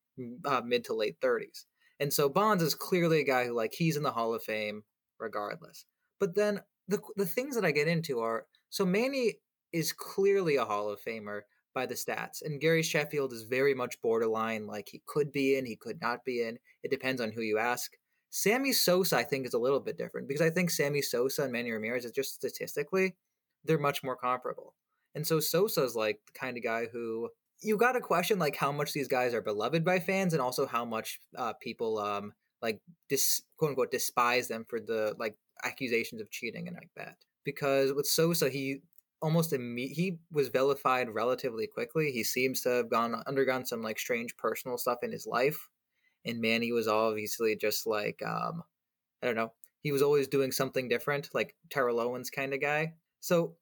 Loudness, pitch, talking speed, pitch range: -31 LUFS, 140 Hz, 205 wpm, 120-175 Hz